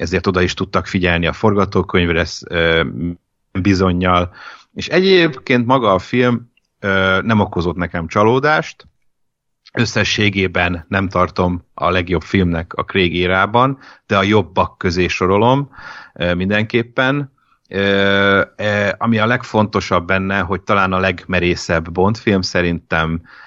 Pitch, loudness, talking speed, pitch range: 95 Hz, -16 LUFS, 110 wpm, 90-110 Hz